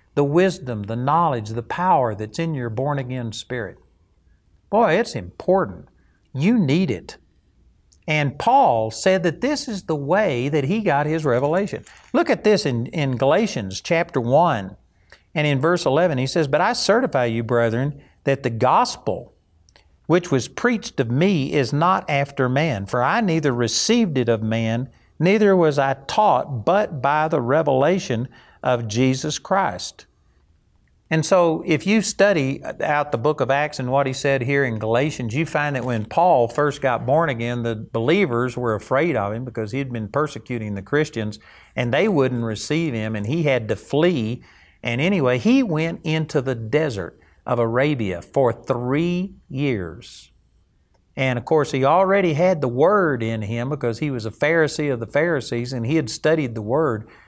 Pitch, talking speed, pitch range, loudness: 135 Hz, 175 wpm, 115-160 Hz, -21 LUFS